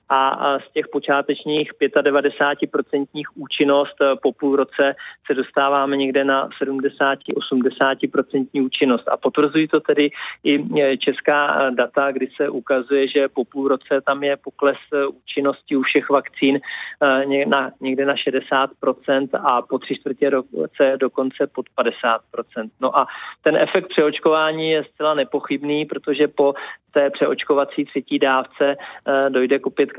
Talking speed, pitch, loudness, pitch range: 130 wpm, 140 Hz, -20 LUFS, 135-145 Hz